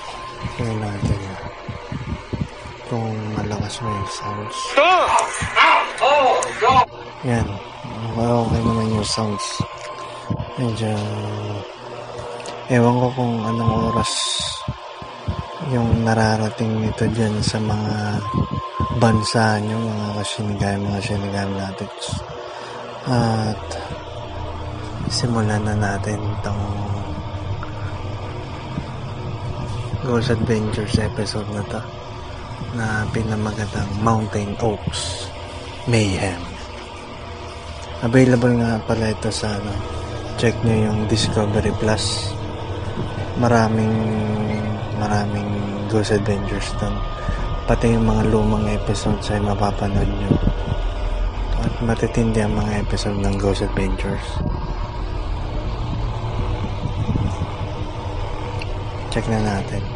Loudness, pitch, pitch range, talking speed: -21 LUFS, 105 Hz, 100-115 Hz, 85 wpm